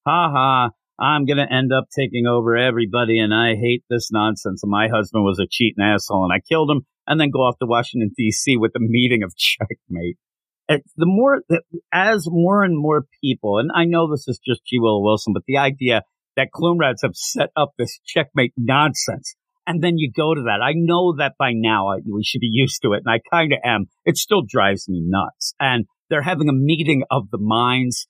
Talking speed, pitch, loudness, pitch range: 215 wpm, 125 Hz, -19 LUFS, 110-155 Hz